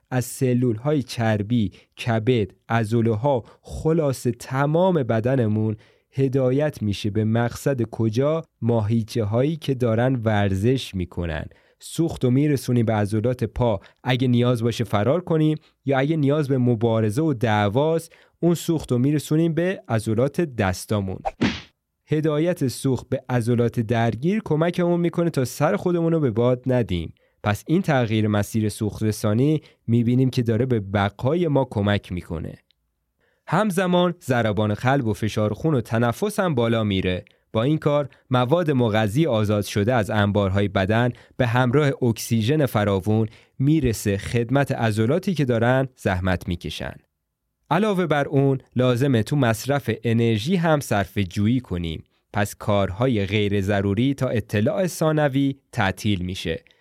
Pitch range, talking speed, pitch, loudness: 110-145 Hz, 135 wpm, 120 Hz, -22 LUFS